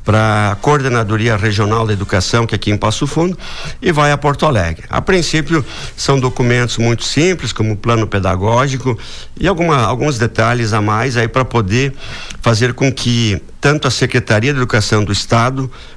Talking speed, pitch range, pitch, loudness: 175 wpm, 110-135 Hz, 120 Hz, -14 LUFS